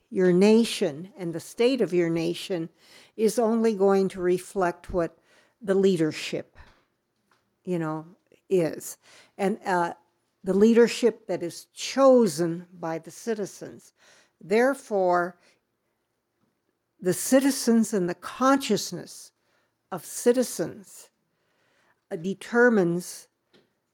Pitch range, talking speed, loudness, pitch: 175-230 Hz, 95 wpm, -25 LUFS, 195 Hz